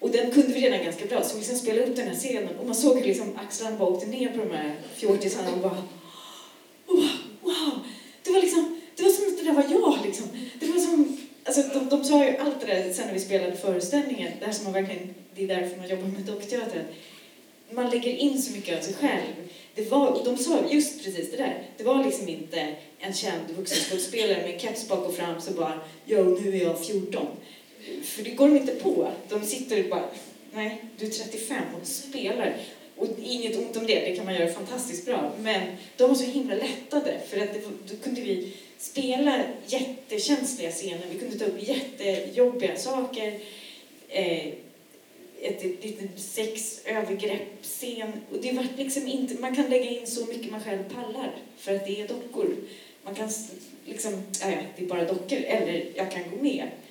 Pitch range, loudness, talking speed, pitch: 195-270 Hz, -27 LUFS, 200 wpm, 225 Hz